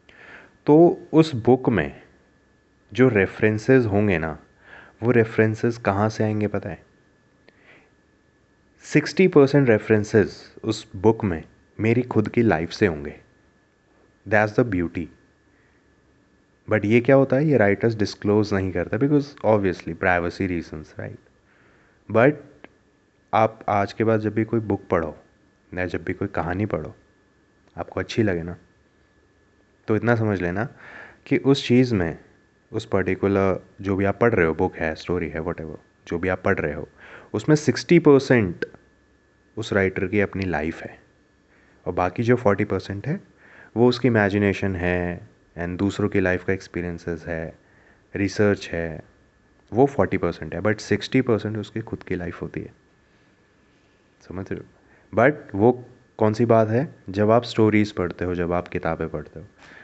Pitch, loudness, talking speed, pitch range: 100 Hz, -22 LUFS, 150 wpm, 90-115 Hz